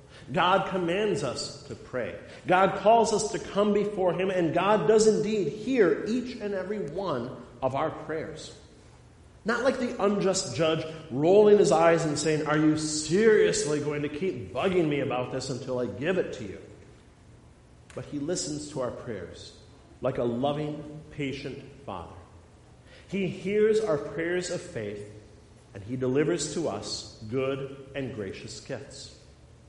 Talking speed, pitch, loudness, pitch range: 155 wpm, 150 Hz, -27 LUFS, 130-190 Hz